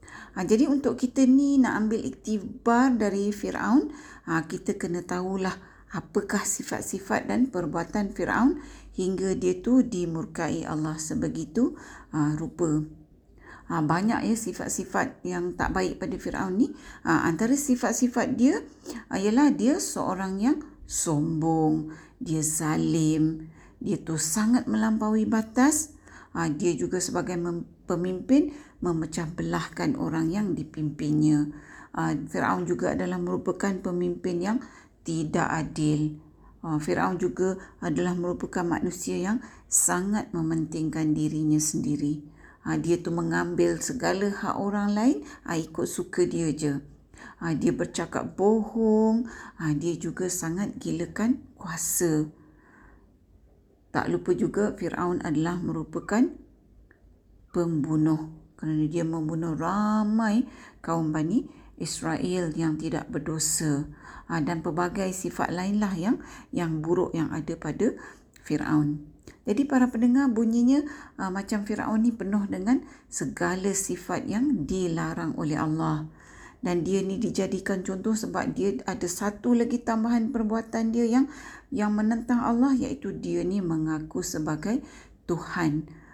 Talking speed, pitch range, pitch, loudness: 120 wpm, 160-230 Hz, 185 Hz, -27 LUFS